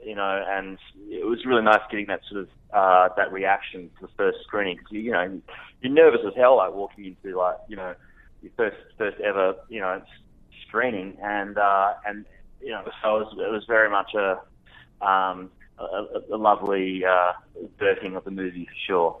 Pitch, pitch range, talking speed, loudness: 100 Hz, 95-110 Hz, 195 wpm, -24 LUFS